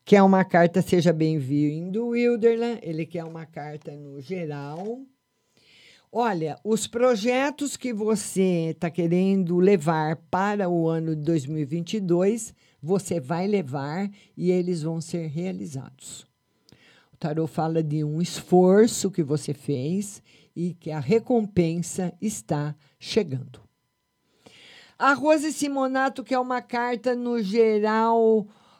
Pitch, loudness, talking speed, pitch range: 180 Hz, -24 LUFS, 115 wpm, 160-220 Hz